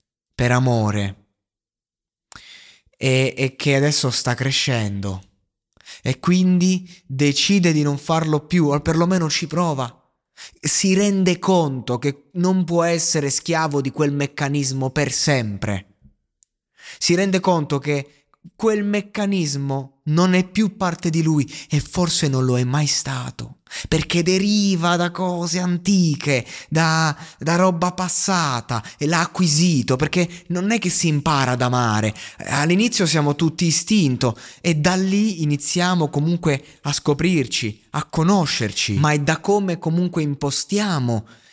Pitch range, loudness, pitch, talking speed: 135-180 Hz, -19 LUFS, 155 Hz, 130 wpm